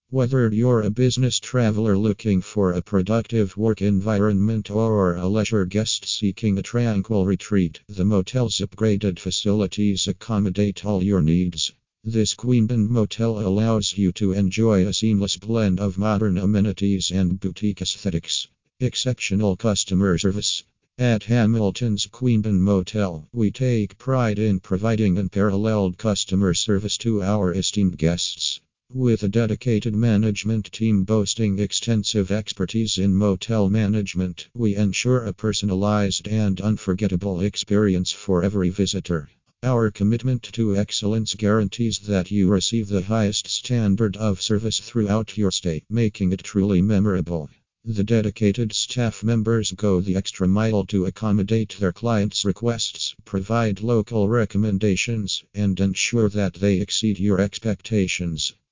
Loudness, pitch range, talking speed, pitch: -22 LUFS, 95-110 Hz, 130 wpm, 105 Hz